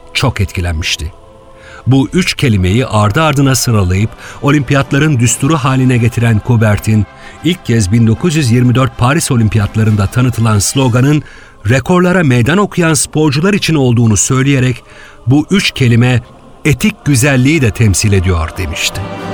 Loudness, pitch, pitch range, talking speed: -11 LUFS, 125 Hz, 110-145 Hz, 110 wpm